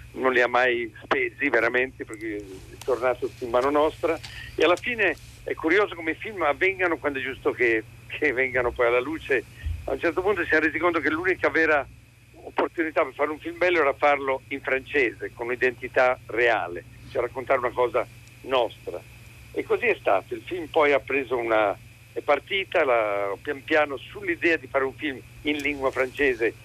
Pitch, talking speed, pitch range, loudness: 135 Hz, 180 wpm, 120-160 Hz, -24 LUFS